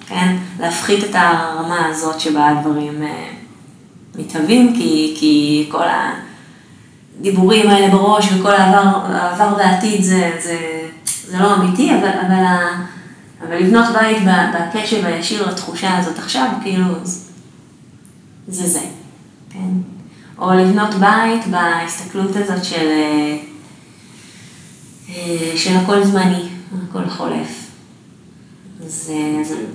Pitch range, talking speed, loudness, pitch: 165-200 Hz, 100 wpm, -15 LUFS, 185 Hz